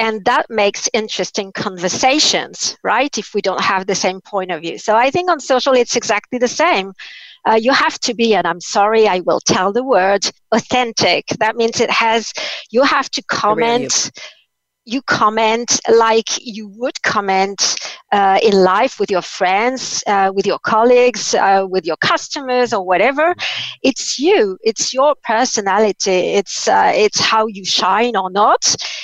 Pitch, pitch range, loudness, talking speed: 220 Hz, 195-250 Hz, -15 LUFS, 165 wpm